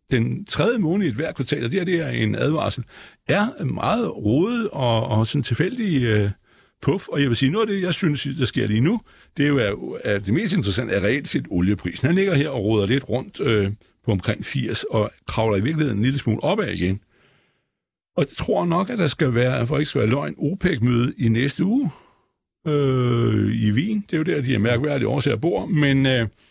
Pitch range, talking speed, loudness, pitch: 110-155 Hz, 225 wpm, -22 LUFS, 130 Hz